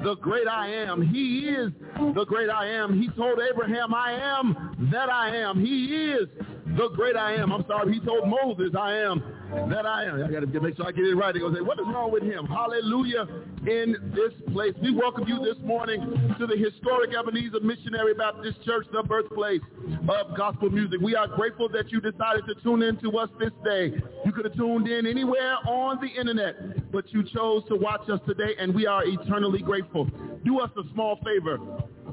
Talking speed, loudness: 205 wpm, -26 LUFS